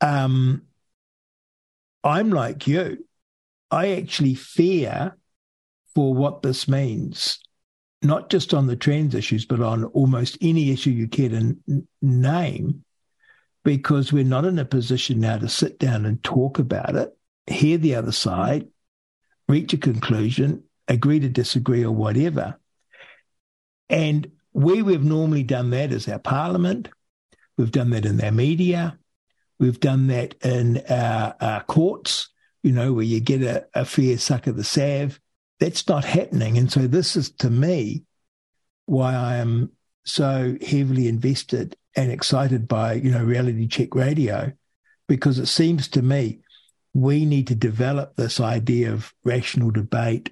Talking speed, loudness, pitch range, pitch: 145 wpm, -22 LUFS, 120-150 Hz, 135 Hz